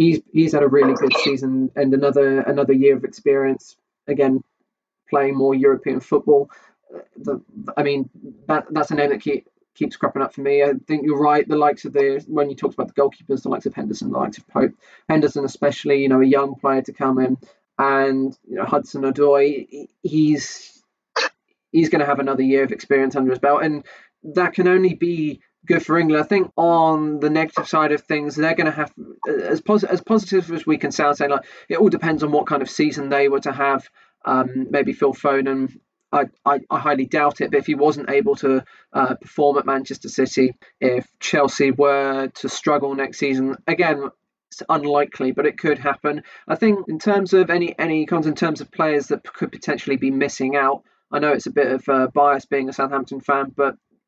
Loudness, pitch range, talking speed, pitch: -19 LUFS, 135-155 Hz, 210 wpm, 140 Hz